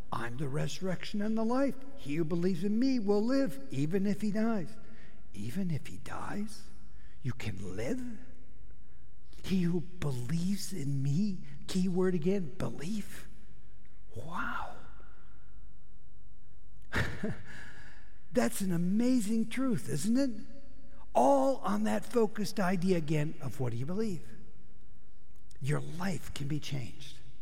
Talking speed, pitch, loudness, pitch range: 125 wpm, 190 Hz, -34 LUFS, 150-220 Hz